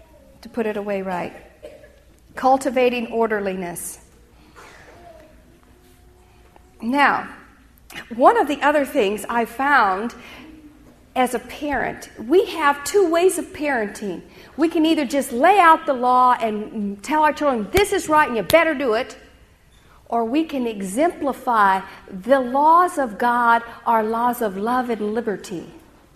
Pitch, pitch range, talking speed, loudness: 250 Hz, 225-305 Hz, 135 wpm, -19 LUFS